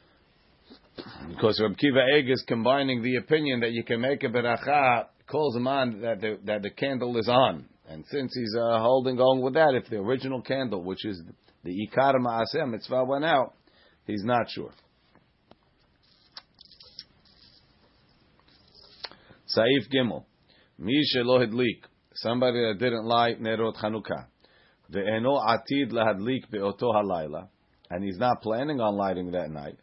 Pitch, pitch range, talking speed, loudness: 120 Hz, 110-130 Hz, 135 wpm, -26 LUFS